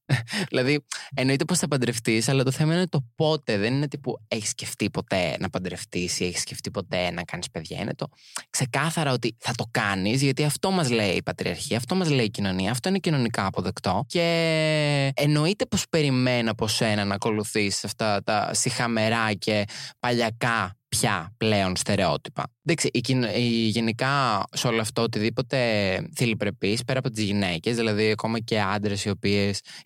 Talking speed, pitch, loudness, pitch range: 170 wpm, 115 Hz, -25 LUFS, 105-140 Hz